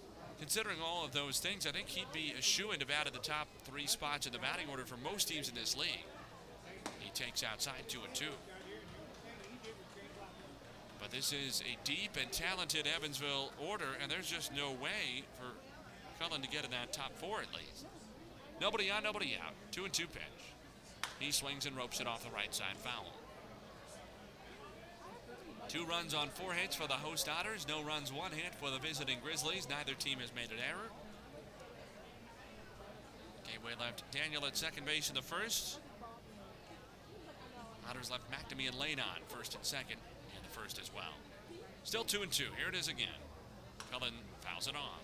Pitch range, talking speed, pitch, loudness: 135-160 Hz, 175 wpm, 145 Hz, -40 LUFS